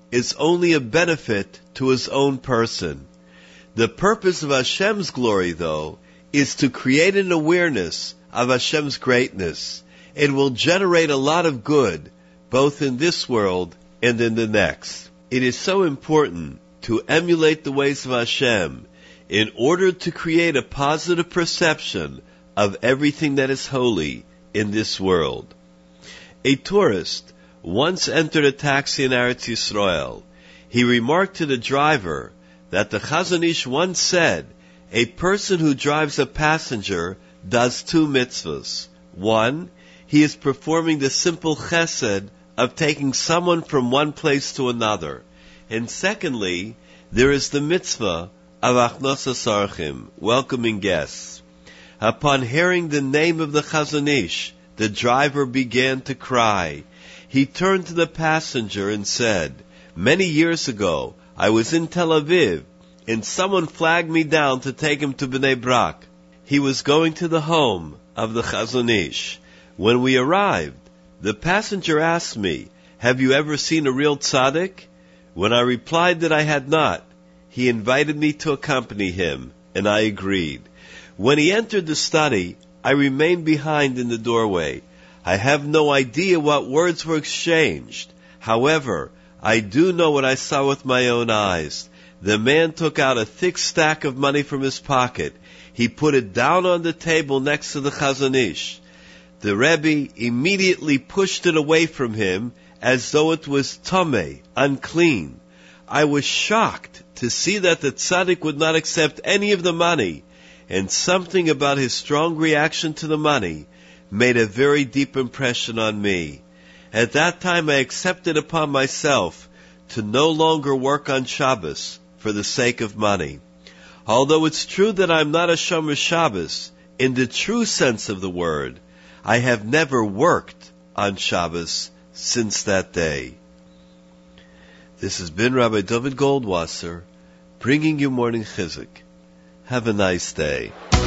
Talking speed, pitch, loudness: 150 wpm, 130 Hz, -20 LUFS